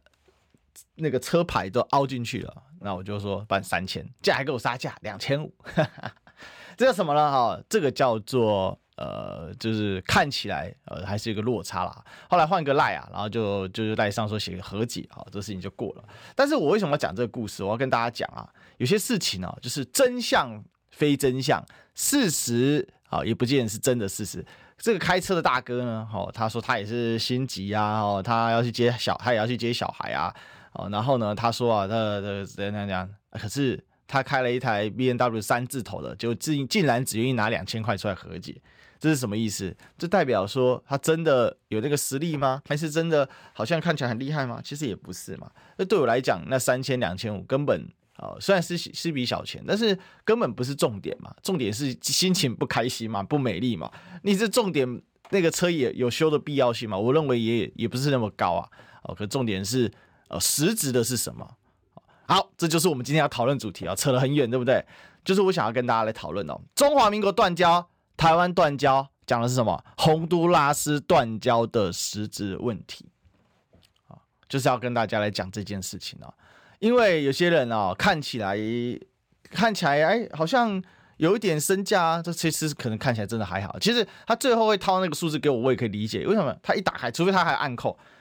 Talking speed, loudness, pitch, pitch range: 305 characters per minute, -25 LUFS, 125 Hz, 110-155 Hz